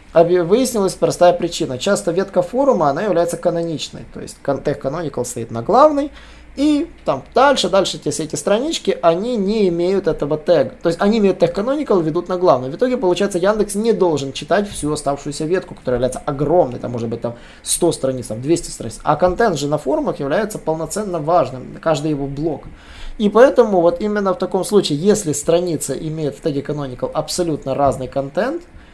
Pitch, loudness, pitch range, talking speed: 170 Hz, -18 LUFS, 150-200 Hz, 175 wpm